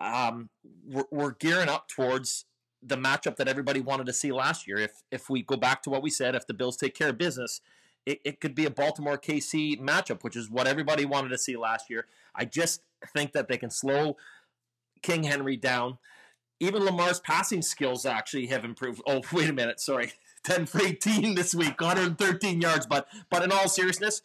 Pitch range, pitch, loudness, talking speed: 125-170 Hz, 140 Hz, -28 LUFS, 205 wpm